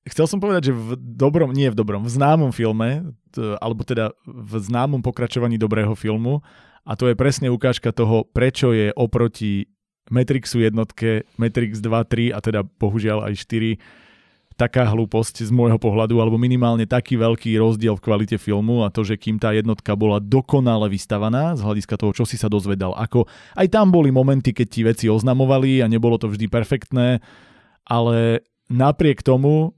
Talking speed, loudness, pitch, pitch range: 170 wpm, -19 LUFS, 115 Hz, 110-125 Hz